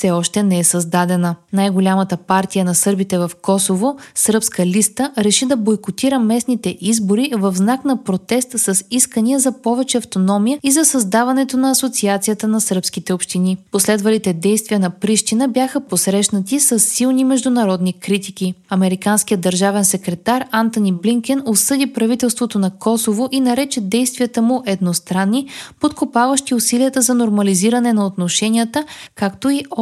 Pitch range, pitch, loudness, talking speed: 190-250 Hz, 215 Hz, -16 LUFS, 135 wpm